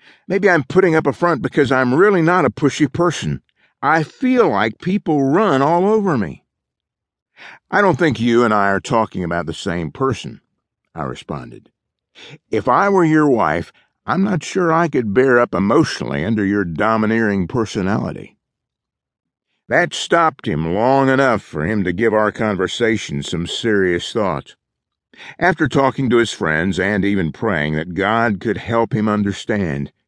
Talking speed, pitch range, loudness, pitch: 160 wpm, 100-160 Hz, -17 LUFS, 120 Hz